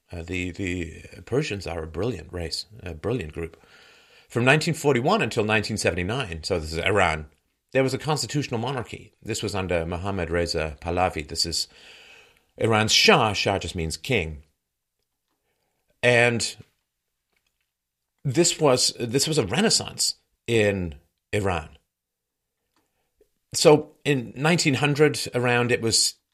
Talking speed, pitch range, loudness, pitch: 120 wpm, 85-125 Hz, -23 LUFS, 100 Hz